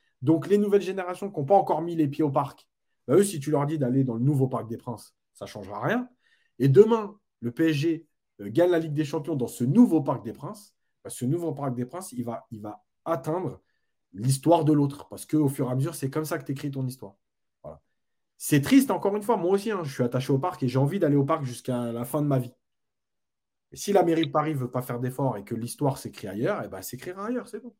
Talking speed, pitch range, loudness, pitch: 265 wpm, 125-170 Hz, -26 LUFS, 145 Hz